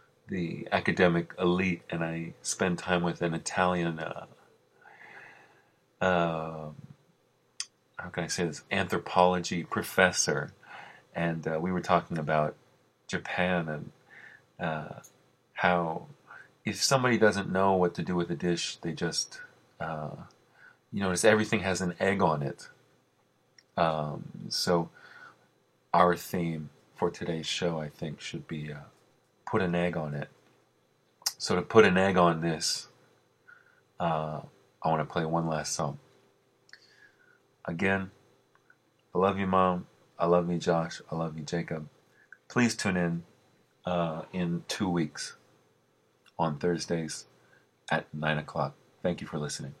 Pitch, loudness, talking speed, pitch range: 85 Hz, -30 LUFS, 135 wpm, 80-90 Hz